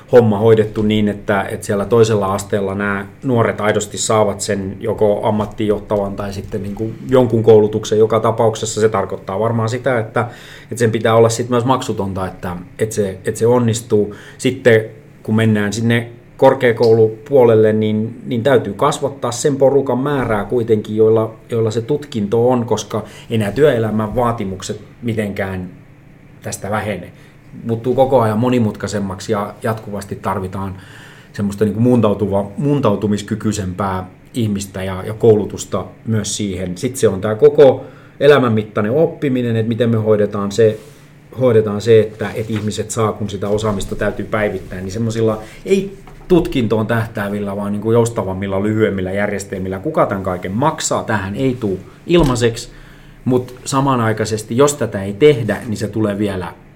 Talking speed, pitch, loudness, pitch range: 140 wpm, 110 Hz, -16 LUFS, 105-120 Hz